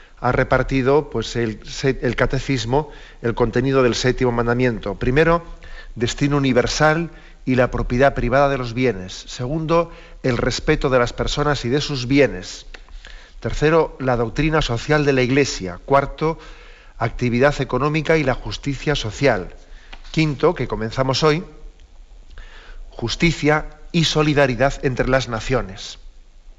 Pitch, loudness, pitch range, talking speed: 135 Hz, -19 LUFS, 120-150 Hz, 125 wpm